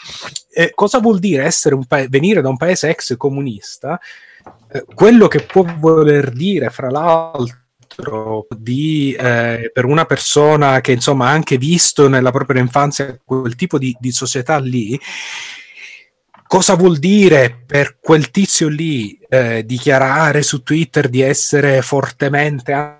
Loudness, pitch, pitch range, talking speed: -13 LUFS, 145 Hz, 130-160 Hz, 140 wpm